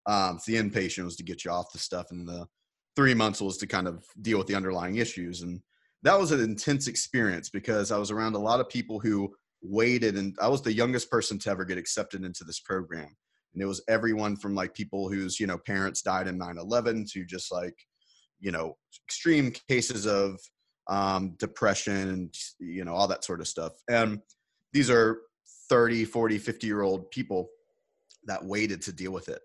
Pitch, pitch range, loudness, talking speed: 105 Hz, 95-115 Hz, -29 LUFS, 205 wpm